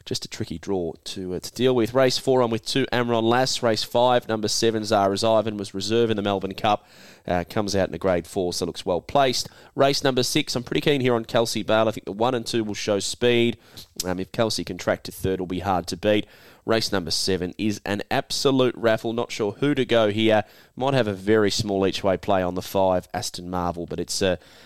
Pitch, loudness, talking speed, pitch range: 110 Hz, -23 LUFS, 245 wpm, 95-120 Hz